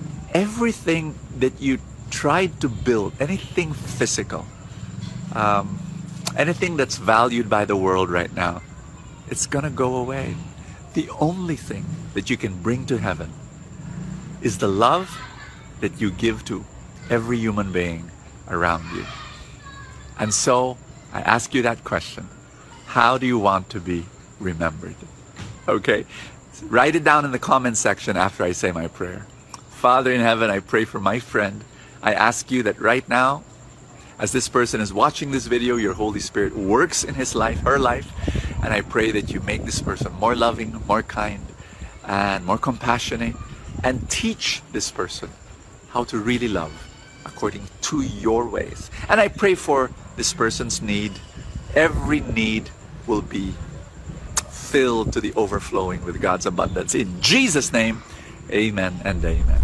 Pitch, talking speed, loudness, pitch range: 120 Hz, 155 wpm, -22 LUFS, 100-135 Hz